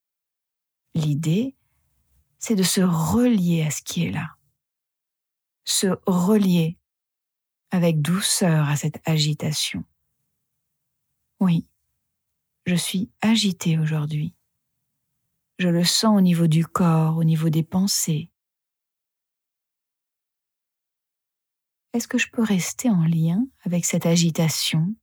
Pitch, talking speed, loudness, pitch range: 170 Hz, 105 wpm, -21 LUFS, 160-195 Hz